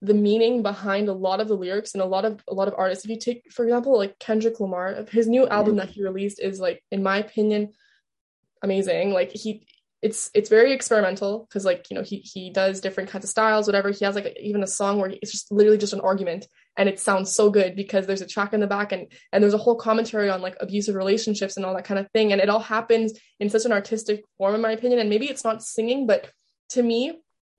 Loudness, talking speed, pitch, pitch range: -23 LUFS, 255 wpm, 210 Hz, 195-220 Hz